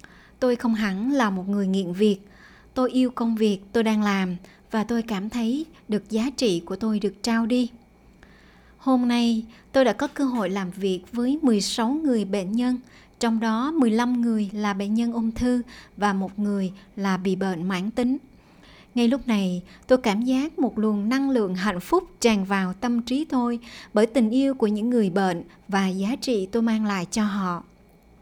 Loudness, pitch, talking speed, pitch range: -24 LUFS, 225 Hz, 190 wpm, 200-245 Hz